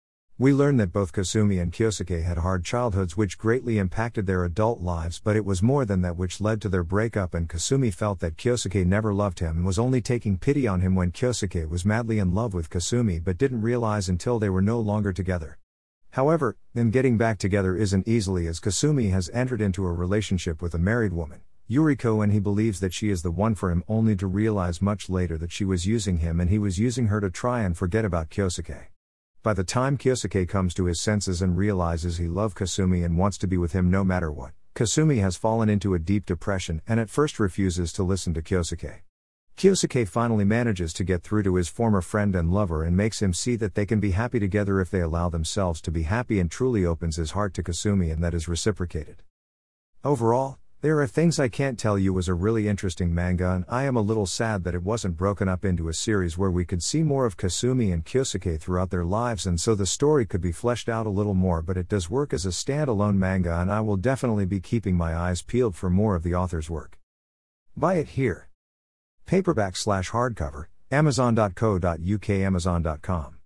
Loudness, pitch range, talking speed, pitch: -25 LUFS, 90-110 Hz, 215 wpm, 100 Hz